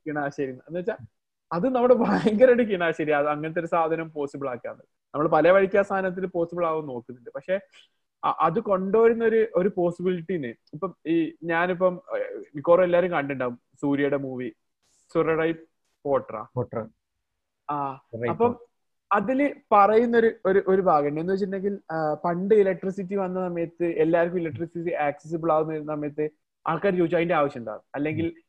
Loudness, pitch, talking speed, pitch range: -24 LUFS, 170 Hz, 120 wpm, 145-195 Hz